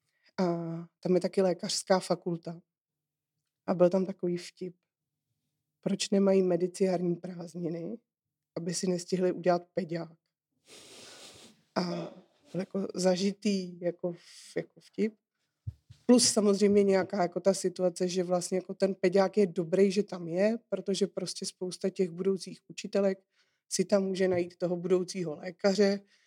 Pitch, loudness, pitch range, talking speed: 185 Hz, -30 LUFS, 175-195 Hz, 130 wpm